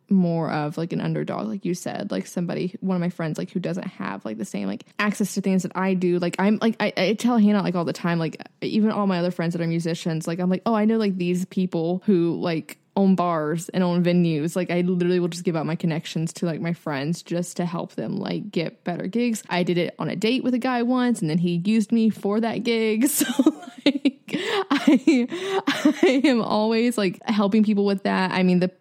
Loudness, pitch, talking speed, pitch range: -23 LUFS, 185 Hz, 245 wpm, 175-225 Hz